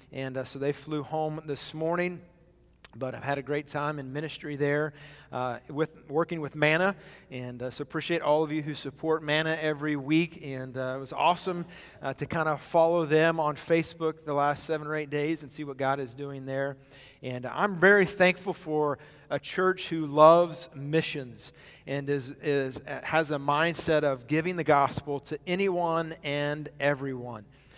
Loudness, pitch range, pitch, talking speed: -28 LUFS, 140-160 Hz, 150 Hz, 180 wpm